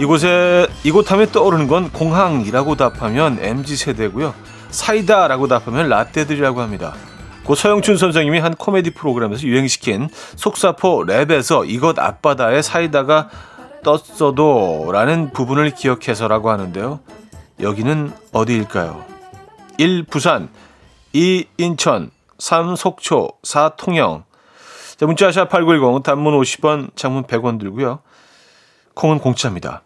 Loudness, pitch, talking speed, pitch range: -16 LUFS, 150 Hz, 270 characters per minute, 130-175 Hz